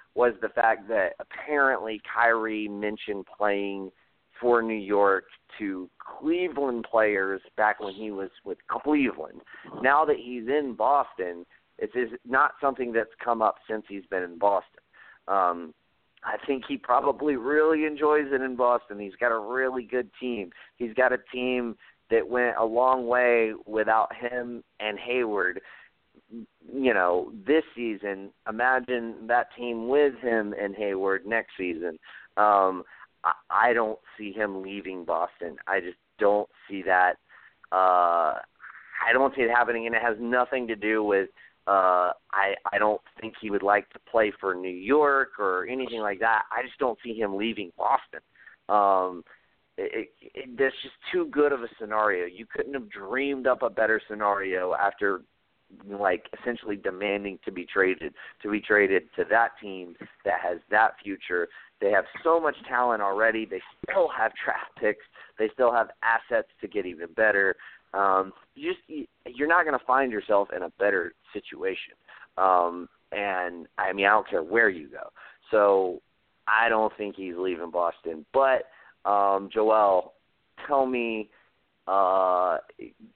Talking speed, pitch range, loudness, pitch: 160 wpm, 100-125 Hz, -26 LUFS, 110 Hz